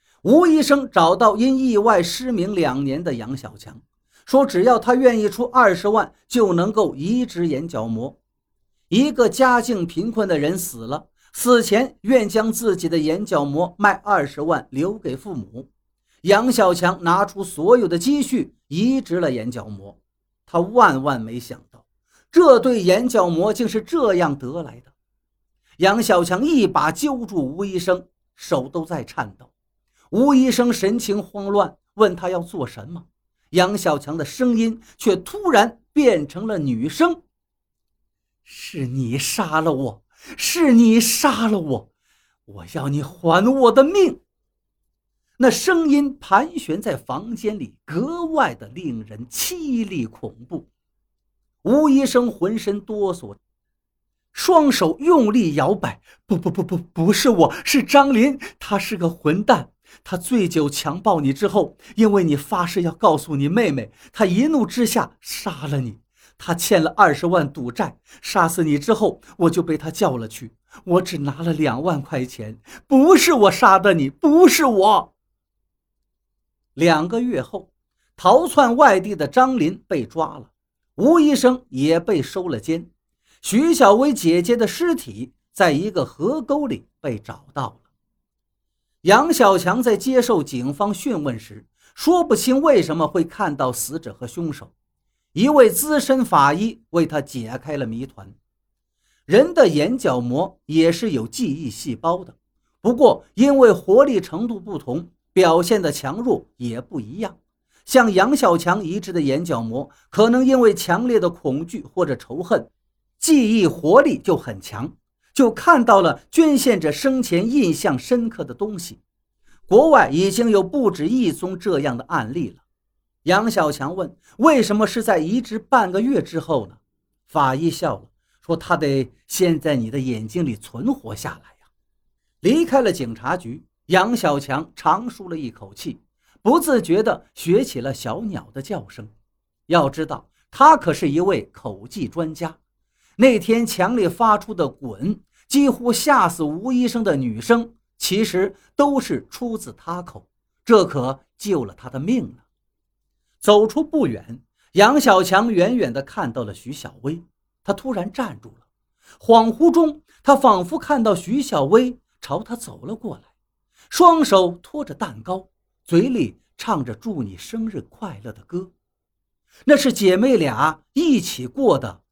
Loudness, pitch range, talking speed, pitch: -18 LUFS, 145-240 Hz, 215 characters per minute, 185 Hz